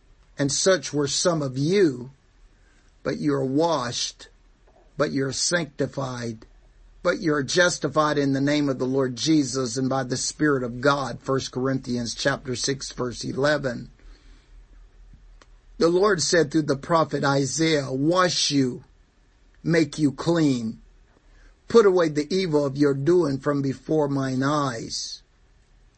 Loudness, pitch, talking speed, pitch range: -23 LUFS, 140 Hz, 140 wpm, 135-155 Hz